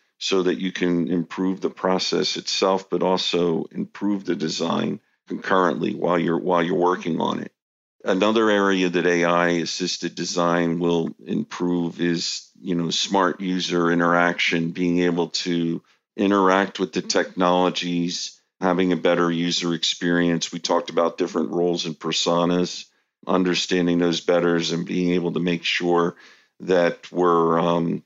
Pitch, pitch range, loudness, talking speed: 85 Hz, 85-90 Hz, -22 LUFS, 140 wpm